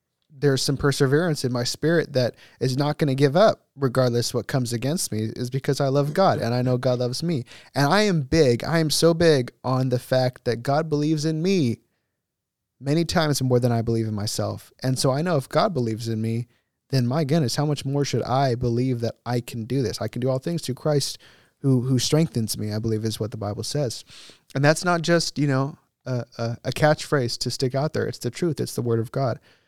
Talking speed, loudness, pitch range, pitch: 235 wpm, -23 LUFS, 120-150 Hz, 130 Hz